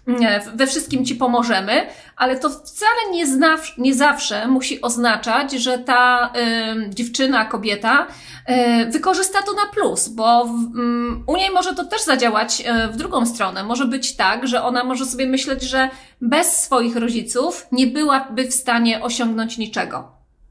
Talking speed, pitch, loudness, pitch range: 160 wpm, 255 Hz, -18 LUFS, 235-280 Hz